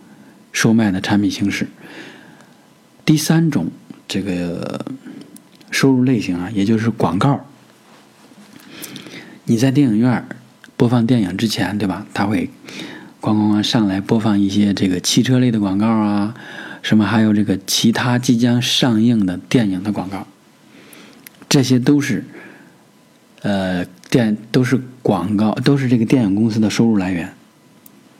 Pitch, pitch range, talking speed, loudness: 110 Hz, 100-125 Hz, 205 characters per minute, -17 LUFS